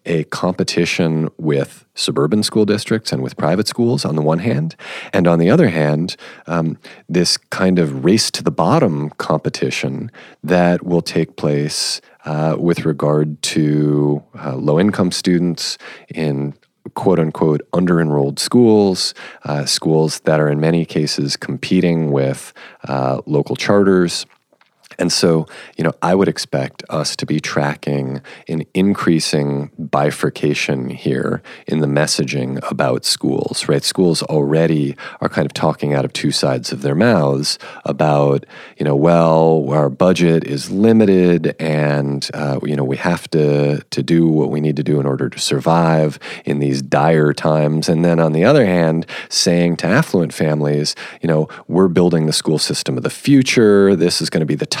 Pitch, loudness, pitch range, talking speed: 80 Hz, -16 LUFS, 75-85 Hz, 160 wpm